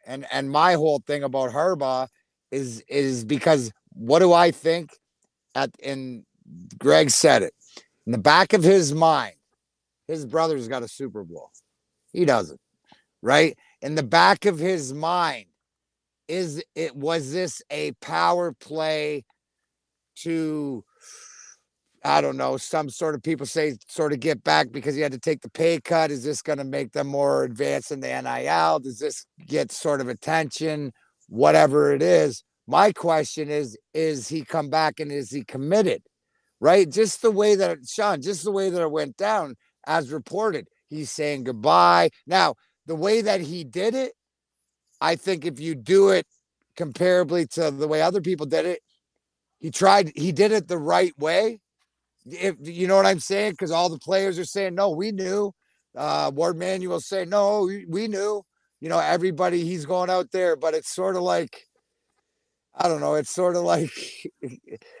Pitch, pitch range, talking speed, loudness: 160 Hz, 140-185 Hz, 175 wpm, -22 LUFS